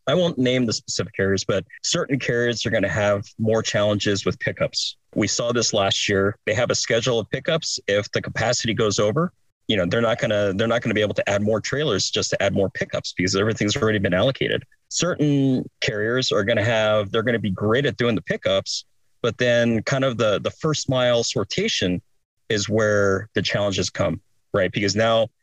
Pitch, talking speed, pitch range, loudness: 110 Hz, 215 wpm, 100-120 Hz, -22 LUFS